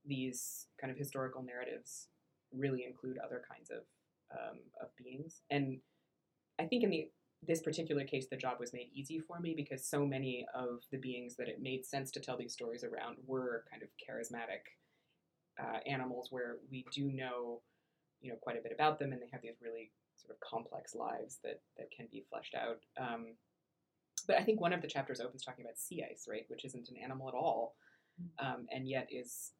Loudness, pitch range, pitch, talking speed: -42 LUFS, 125-145 Hz, 130 Hz, 200 wpm